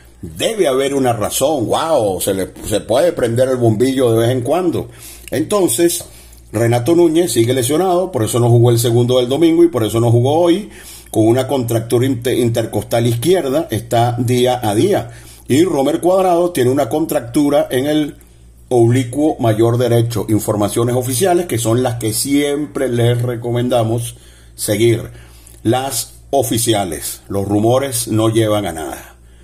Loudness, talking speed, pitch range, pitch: -15 LUFS, 150 wpm, 110-135 Hz, 120 Hz